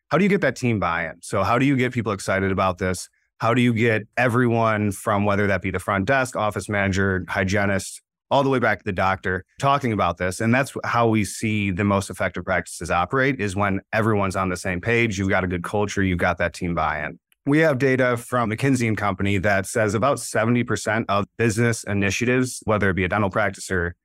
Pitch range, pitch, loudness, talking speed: 95-115 Hz, 105 Hz, -22 LUFS, 220 wpm